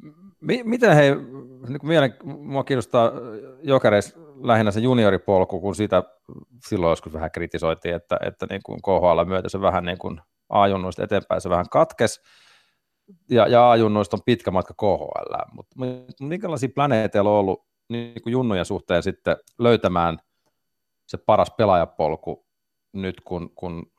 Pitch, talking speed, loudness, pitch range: 110 Hz, 130 wpm, -21 LUFS, 95-130 Hz